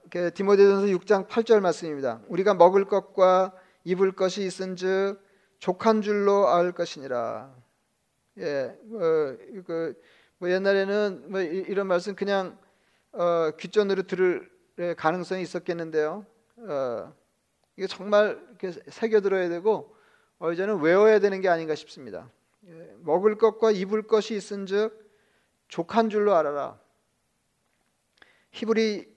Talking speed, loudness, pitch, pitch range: 250 characters per minute, -25 LUFS, 195 Hz, 180-210 Hz